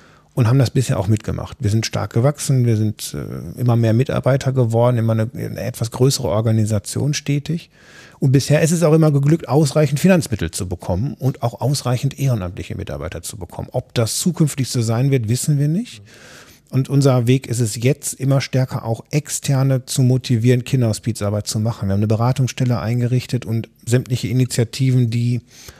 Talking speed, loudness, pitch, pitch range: 170 wpm, -18 LUFS, 125 Hz, 115-135 Hz